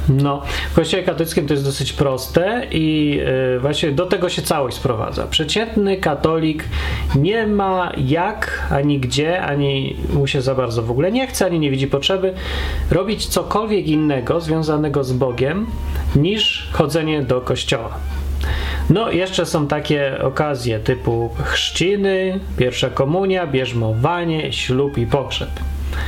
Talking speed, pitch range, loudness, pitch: 135 wpm, 130-175 Hz, -19 LUFS, 145 Hz